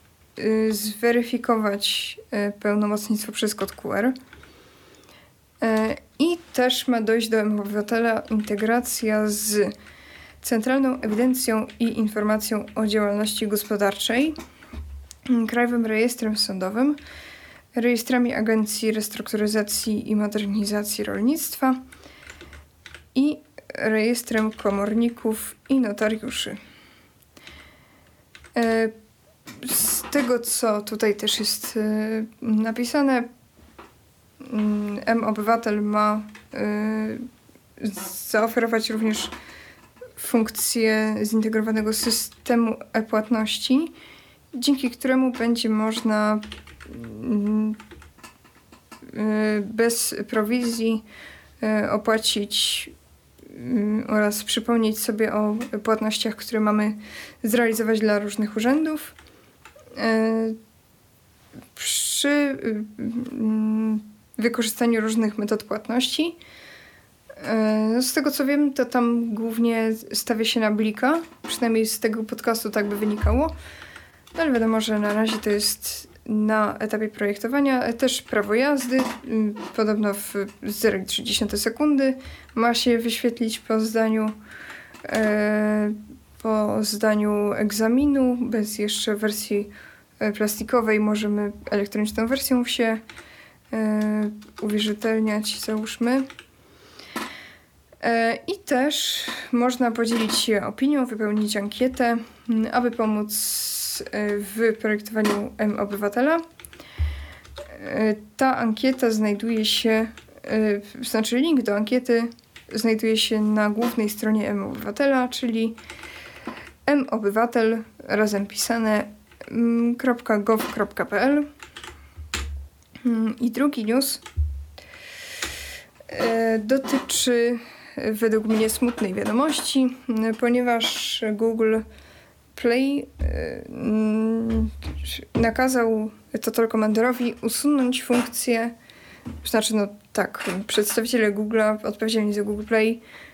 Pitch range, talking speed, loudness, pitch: 215-240 Hz, 80 wpm, -23 LUFS, 225 Hz